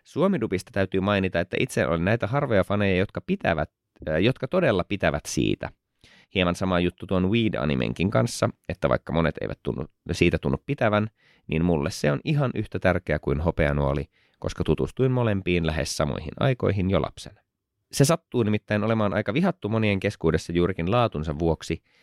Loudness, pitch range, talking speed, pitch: -25 LUFS, 80-110 Hz, 155 wpm, 95 Hz